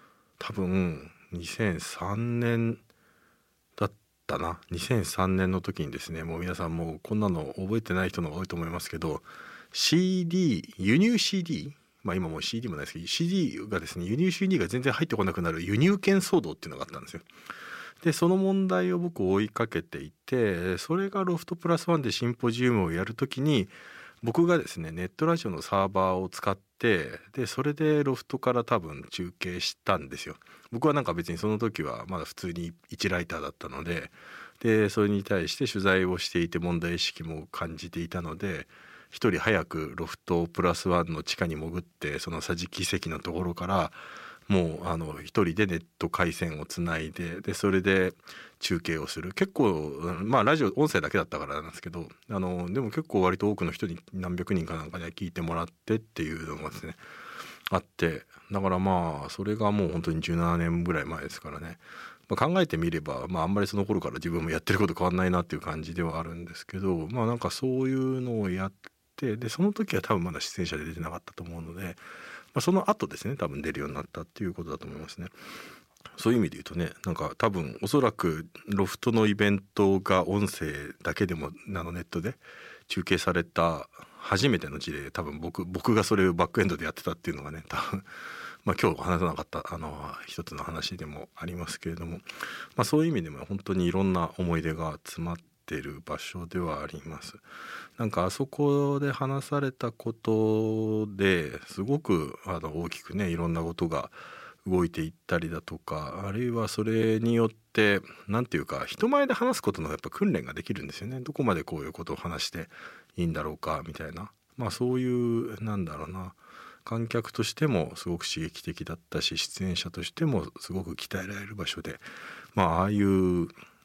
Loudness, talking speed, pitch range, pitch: -29 LUFS, 370 characters per minute, 85-115 Hz, 95 Hz